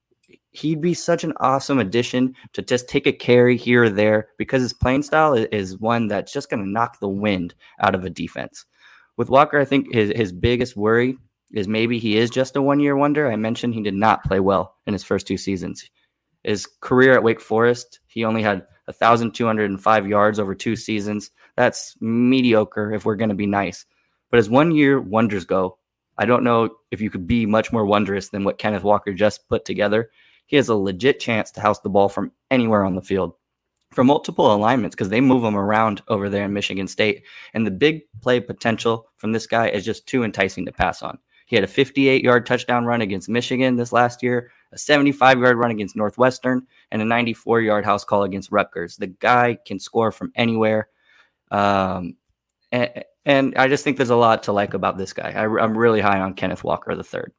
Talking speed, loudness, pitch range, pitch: 210 wpm, -20 LUFS, 105-125 Hz, 115 Hz